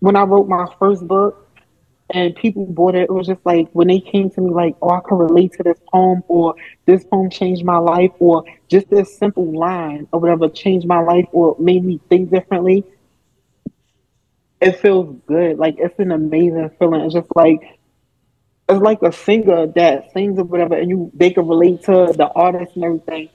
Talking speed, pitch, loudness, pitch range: 200 wpm, 175 Hz, -15 LUFS, 170-185 Hz